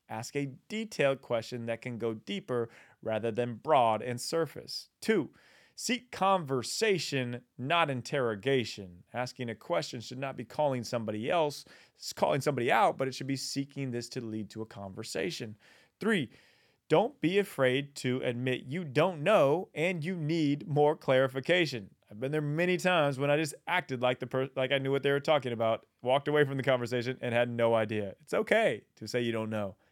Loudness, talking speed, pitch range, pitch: -31 LUFS, 185 wpm, 120-145 Hz, 130 Hz